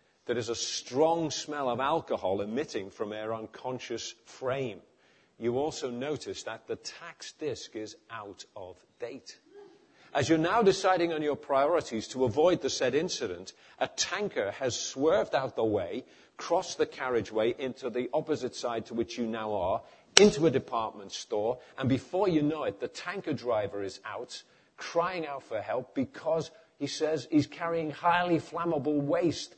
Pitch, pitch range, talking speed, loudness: 150 Hz, 125-170 Hz, 160 wpm, -30 LUFS